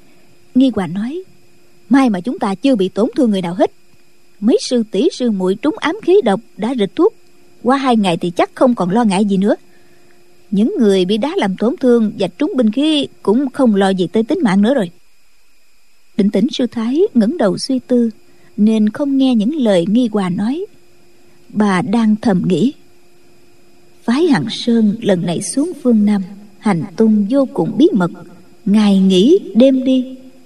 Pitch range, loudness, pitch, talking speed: 200-265 Hz, -15 LUFS, 230 Hz, 185 wpm